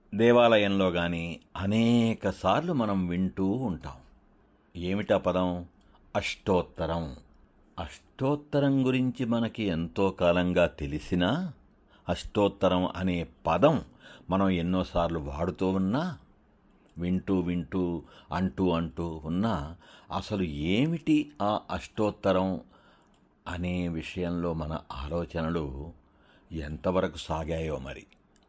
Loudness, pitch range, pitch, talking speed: -29 LUFS, 85-100 Hz, 90 Hz, 80 wpm